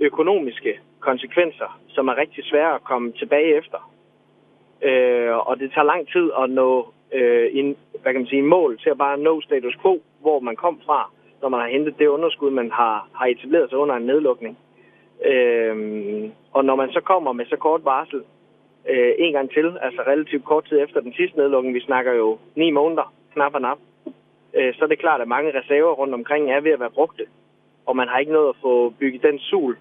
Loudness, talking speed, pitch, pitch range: -20 LUFS, 210 wpm, 145 Hz, 130-175 Hz